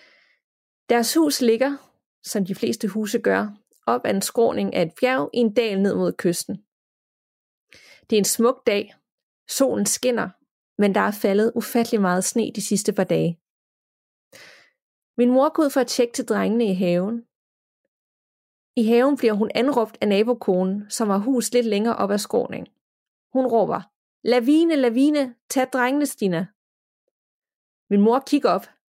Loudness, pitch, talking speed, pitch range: -21 LUFS, 230 Hz, 155 wpm, 205-250 Hz